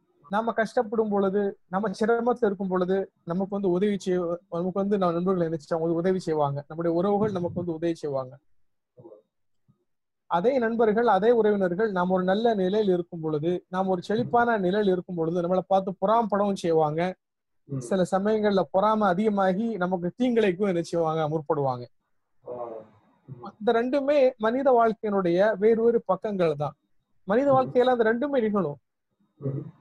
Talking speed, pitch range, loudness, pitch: 125 wpm, 170-220 Hz, -25 LUFS, 190 Hz